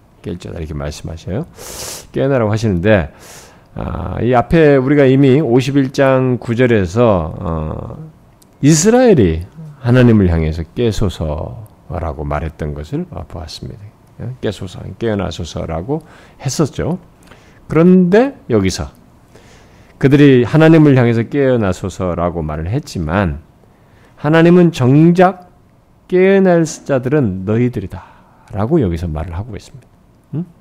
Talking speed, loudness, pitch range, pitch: 250 characters per minute, -14 LUFS, 90-145 Hz, 115 Hz